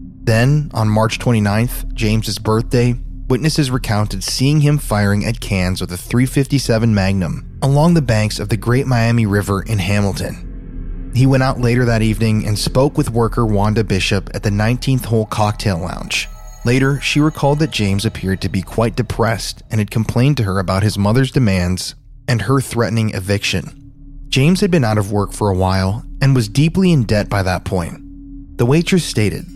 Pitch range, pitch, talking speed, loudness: 100-130 Hz, 115 Hz, 180 wpm, -16 LUFS